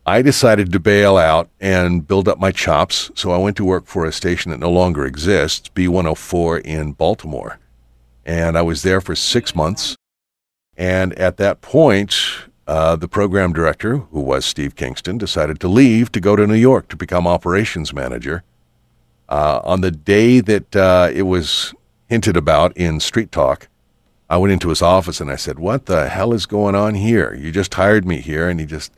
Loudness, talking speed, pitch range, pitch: -16 LUFS, 190 wpm, 80-100 Hz, 90 Hz